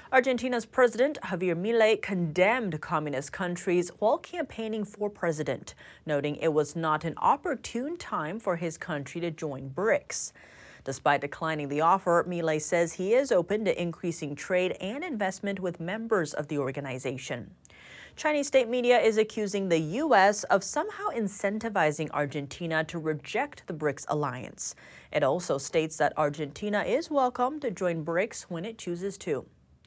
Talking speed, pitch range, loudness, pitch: 145 wpm, 155-220 Hz, -29 LUFS, 180 Hz